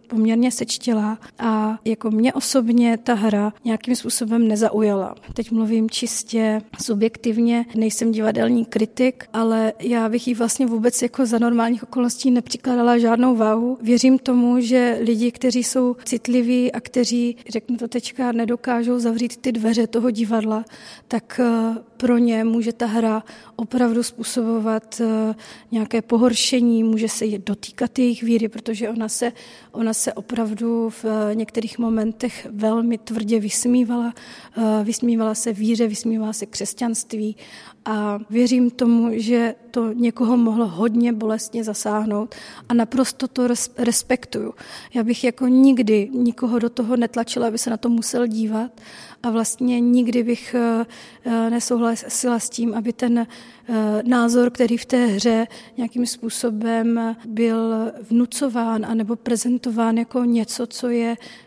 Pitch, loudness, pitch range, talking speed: 235 Hz, -20 LUFS, 225-245 Hz, 130 wpm